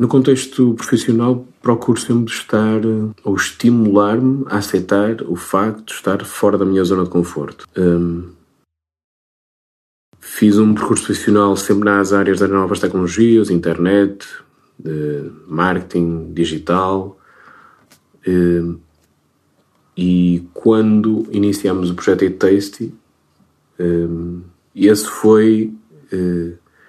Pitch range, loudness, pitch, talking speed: 85-110 Hz, -16 LUFS, 100 Hz, 105 wpm